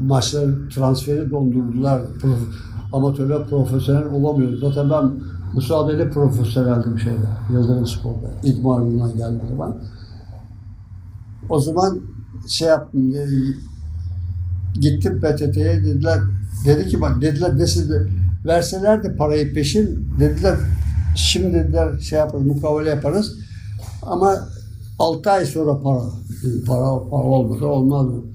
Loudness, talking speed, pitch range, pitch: -19 LUFS, 110 wpm, 100-145 Hz, 125 Hz